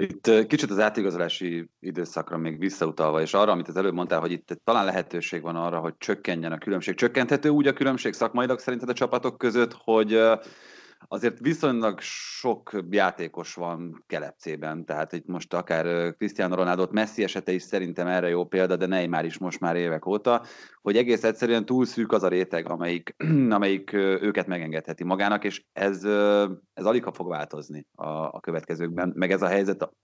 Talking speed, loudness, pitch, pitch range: 175 wpm, -26 LUFS, 95 Hz, 85-110 Hz